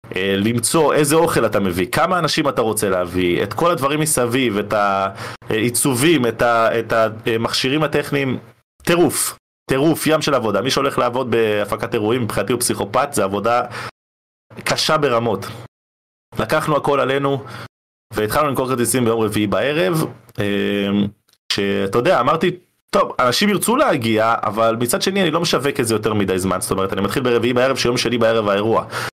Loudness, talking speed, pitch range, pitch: -18 LUFS, 150 wpm, 105-140 Hz, 115 Hz